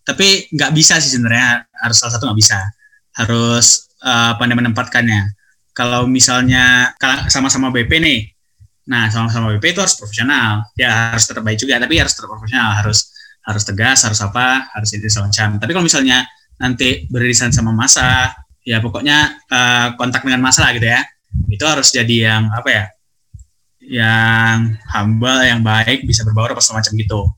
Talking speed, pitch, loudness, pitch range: 160 wpm, 120 Hz, -12 LUFS, 110-130 Hz